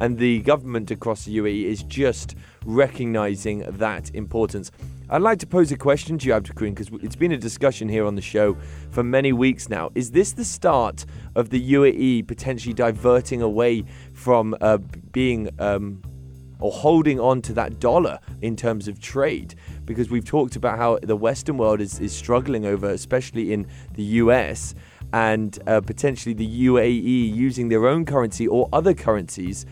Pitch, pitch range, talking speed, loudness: 115 Hz, 105-125 Hz, 170 wpm, -22 LUFS